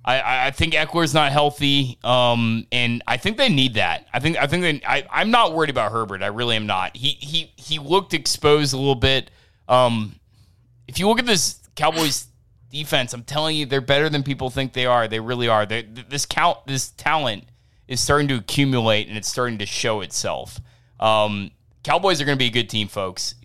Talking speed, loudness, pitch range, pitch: 210 wpm, -20 LUFS, 110-145 Hz, 125 Hz